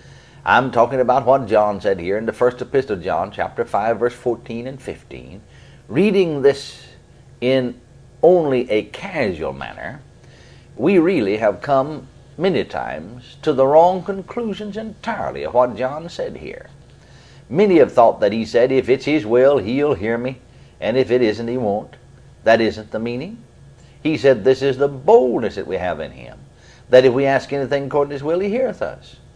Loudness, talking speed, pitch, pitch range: -18 LUFS, 180 wpm, 135 Hz, 125-145 Hz